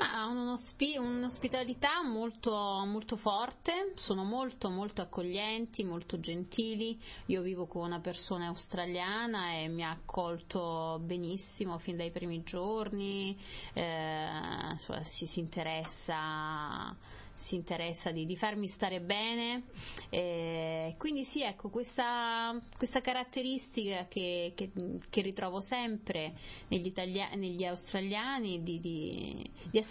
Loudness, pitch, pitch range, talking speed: -37 LUFS, 190 Hz, 170-225 Hz, 120 wpm